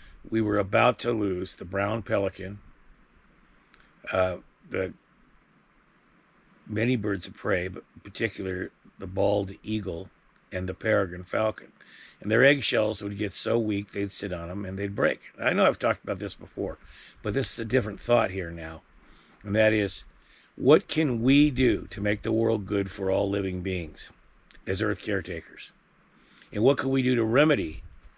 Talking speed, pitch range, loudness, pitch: 170 wpm, 95-110 Hz, -27 LUFS, 100 Hz